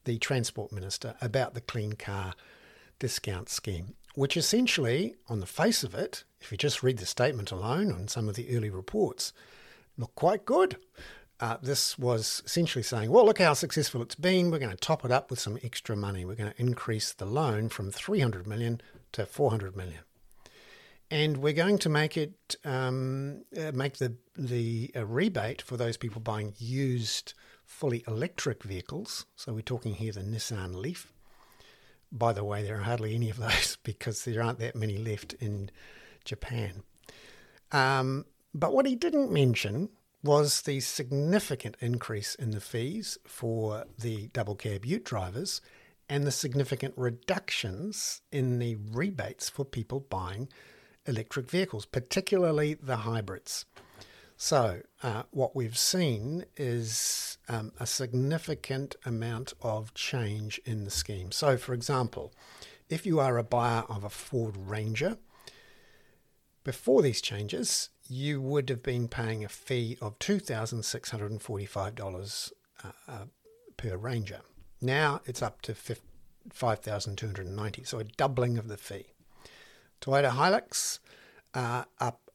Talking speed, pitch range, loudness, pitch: 150 wpm, 110-140 Hz, -31 LUFS, 120 Hz